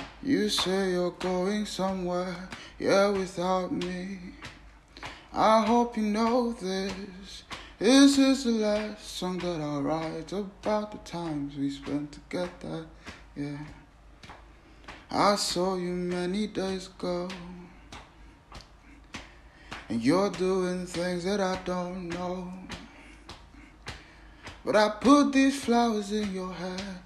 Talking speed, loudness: 110 wpm, -28 LUFS